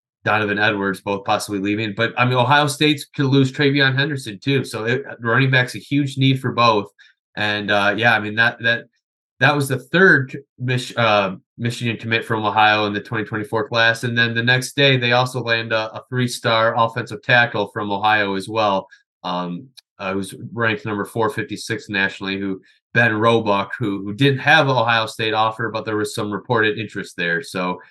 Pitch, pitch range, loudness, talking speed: 115 Hz, 105-125 Hz, -18 LUFS, 190 wpm